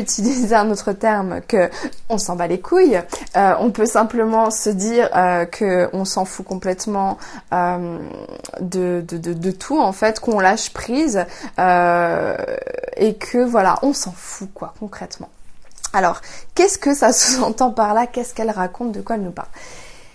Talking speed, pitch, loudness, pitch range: 165 wpm, 215 Hz, -18 LUFS, 185-240 Hz